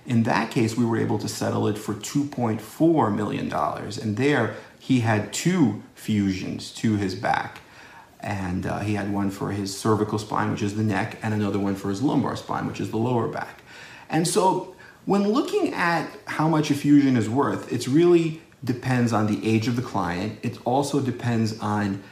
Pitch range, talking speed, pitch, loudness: 105-140 Hz, 190 wpm, 110 Hz, -24 LUFS